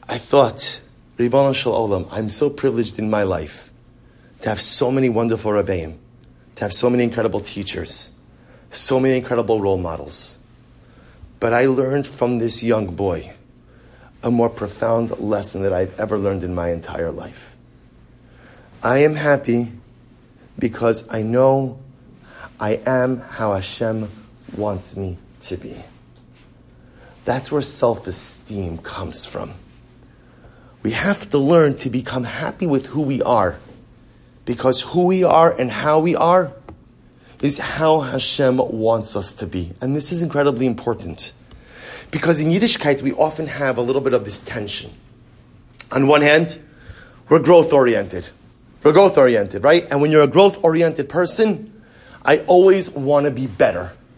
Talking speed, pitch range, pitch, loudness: 145 wpm, 110-145 Hz, 125 Hz, -18 LUFS